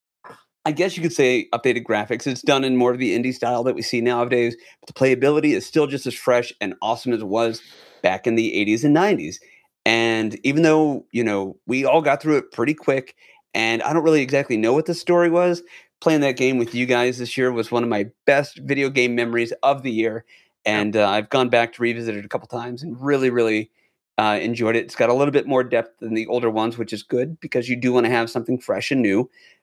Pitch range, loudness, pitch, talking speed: 115-140 Hz, -20 LUFS, 120 Hz, 245 wpm